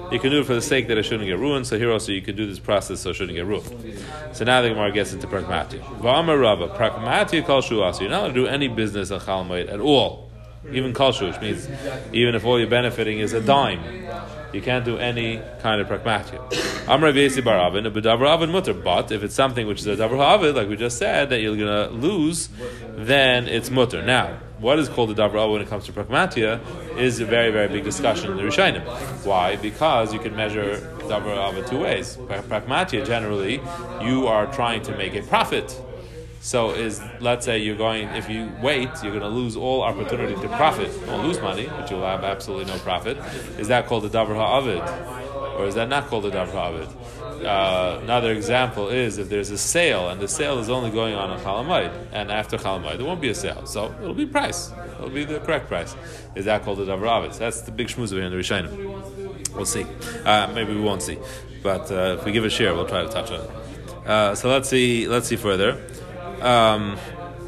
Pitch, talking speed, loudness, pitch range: 115 Hz, 210 wpm, -22 LUFS, 105-125 Hz